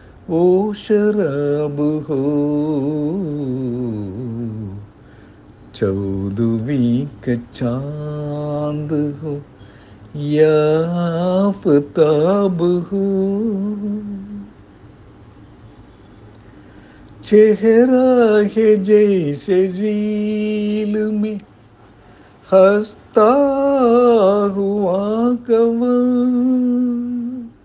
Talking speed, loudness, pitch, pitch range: 35 wpm, -17 LUFS, 180 Hz, 145-210 Hz